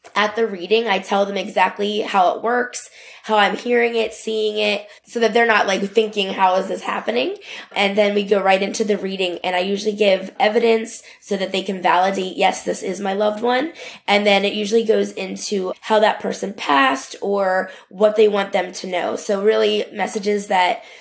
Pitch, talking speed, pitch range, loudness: 205 Hz, 205 wpm, 195-220 Hz, -19 LUFS